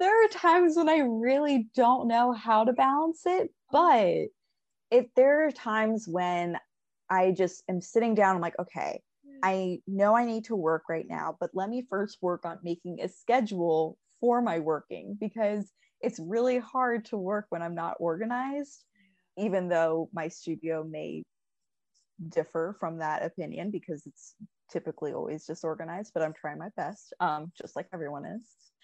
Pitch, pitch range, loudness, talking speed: 195 Hz, 170-245 Hz, -29 LUFS, 165 wpm